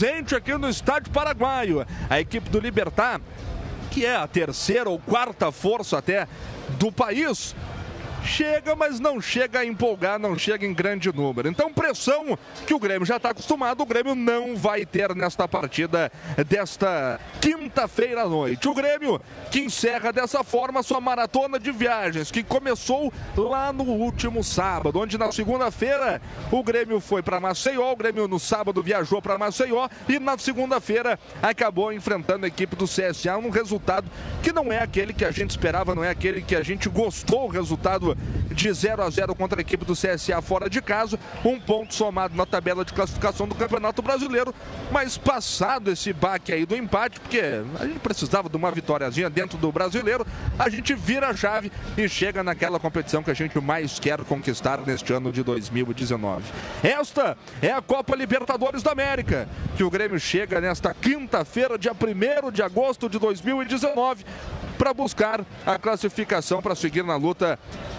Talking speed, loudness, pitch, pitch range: 170 wpm, -24 LUFS, 215 Hz, 185-255 Hz